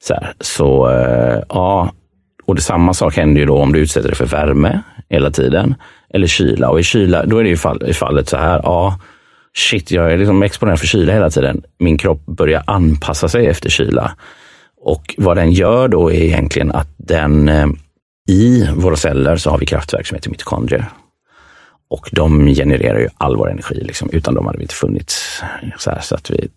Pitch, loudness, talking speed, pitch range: 80 Hz, -14 LUFS, 200 wpm, 75-90 Hz